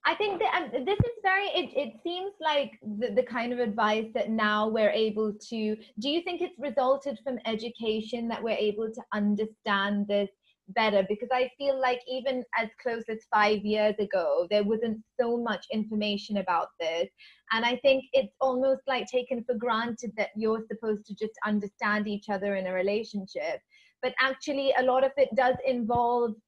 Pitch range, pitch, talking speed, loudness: 210-260 Hz, 230 Hz, 185 wpm, -29 LUFS